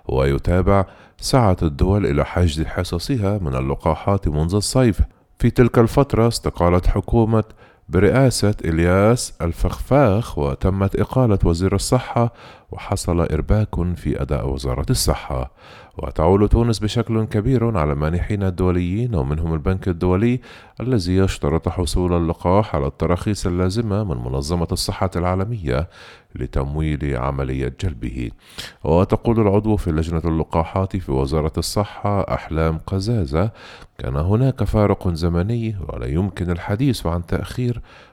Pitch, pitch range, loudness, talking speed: 90 Hz, 80-105 Hz, -20 LUFS, 110 wpm